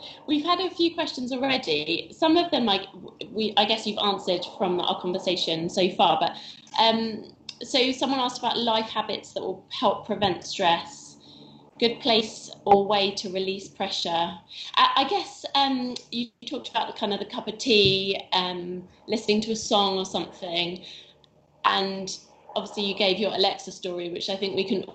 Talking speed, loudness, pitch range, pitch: 175 wpm, -25 LUFS, 185-230 Hz, 205 Hz